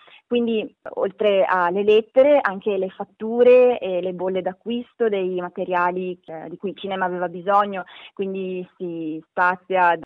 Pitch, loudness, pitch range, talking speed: 185 Hz, -21 LUFS, 180-215 Hz, 145 wpm